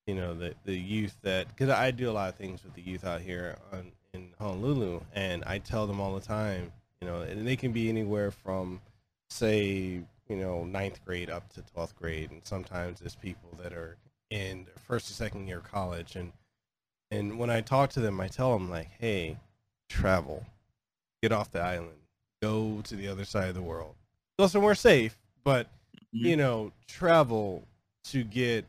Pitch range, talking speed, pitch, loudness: 90-115 Hz, 190 wpm, 100 Hz, -31 LUFS